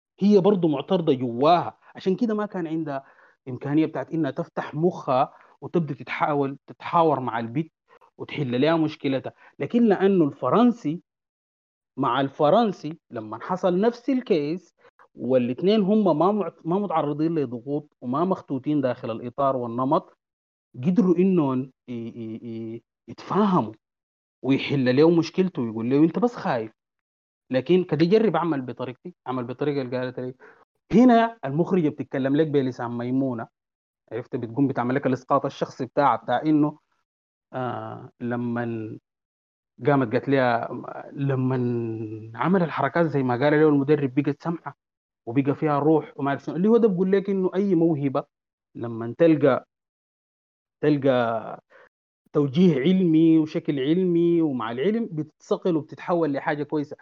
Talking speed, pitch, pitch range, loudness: 130 wpm, 145 Hz, 130-170 Hz, -23 LUFS